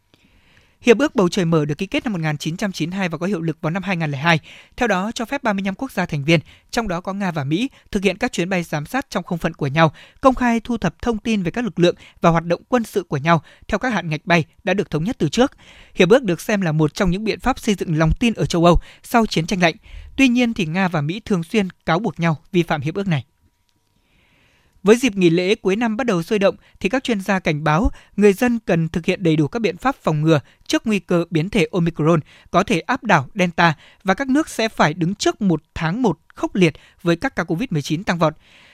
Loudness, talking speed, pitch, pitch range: -19 LUFS, 255 wpm, 180 Hz, 160-220 Hz